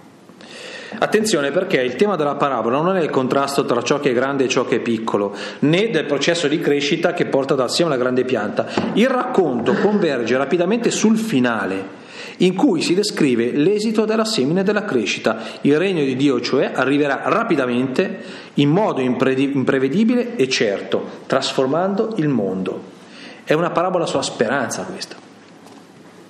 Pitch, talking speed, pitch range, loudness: 160 Hz, 155 wpm, 130-210 Hz, -18 LUFS